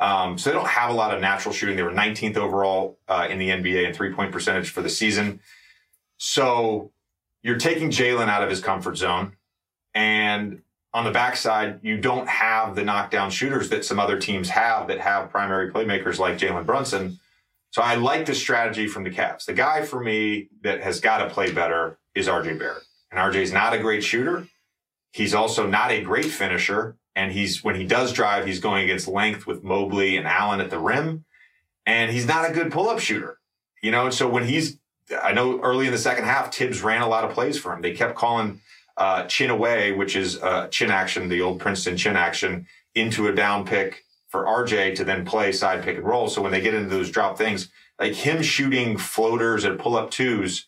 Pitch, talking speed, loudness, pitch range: 105 Hz, 215 wpm, -23 LUFS, 95-120 Hz